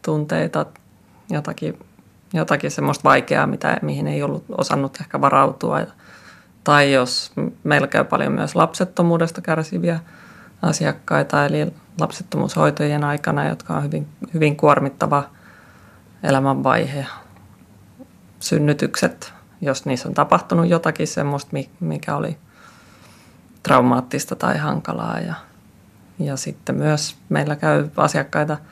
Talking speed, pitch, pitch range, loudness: 100 wpm, 150 Hz, 130-165 Hz, -20 LUFS